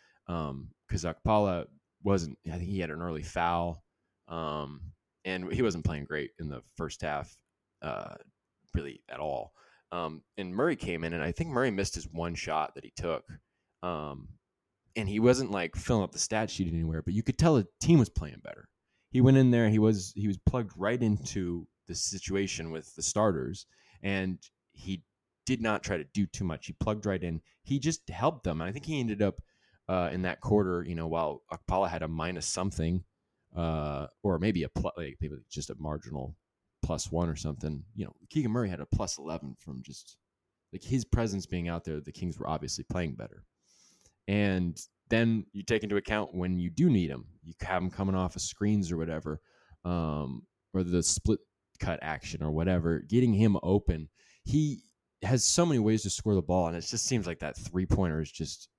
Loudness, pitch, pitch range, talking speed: -31 LUFS, 90 Hz, 85-105 Hz, 200 wpm